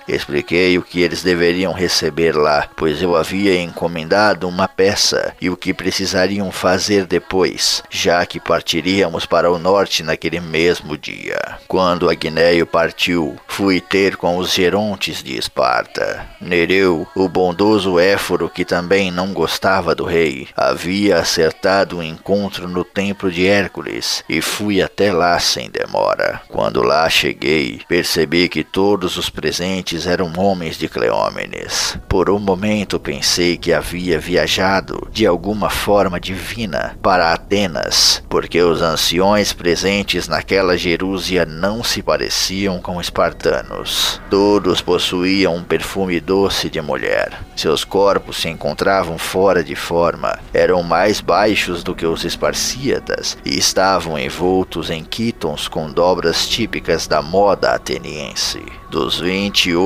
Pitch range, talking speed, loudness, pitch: 85-95 Hz, 130 wpm, -16 LUFS, 90 Hz